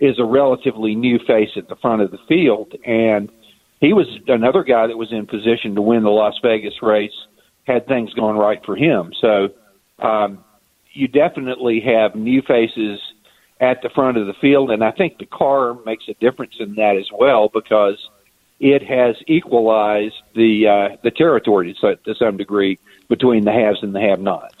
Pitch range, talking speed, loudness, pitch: 105-125 Hz, 185 wpm, -17 LUFS, 110 Hz